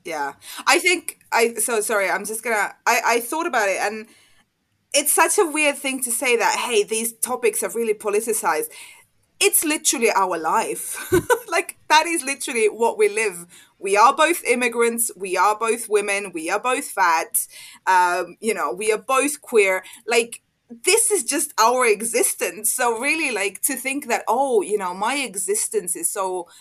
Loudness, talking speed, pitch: -20 LUFS, 175 wpm, 270 Hz